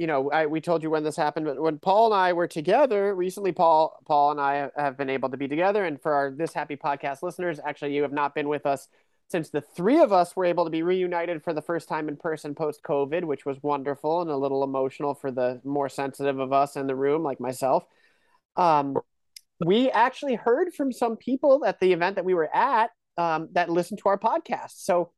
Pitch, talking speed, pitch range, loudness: 160 Hz, 235 wpm, 140-180 Hz, -25 LUFS